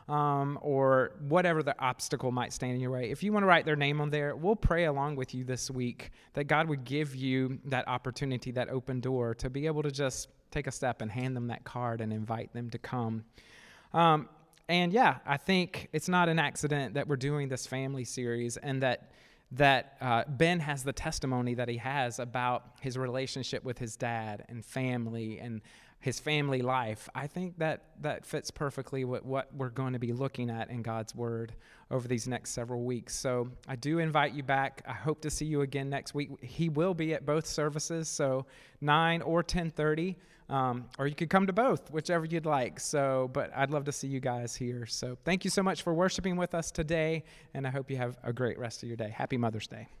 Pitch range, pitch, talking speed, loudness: 125-150 Hz, 135 Hz, 220 wpm, -32 LUFS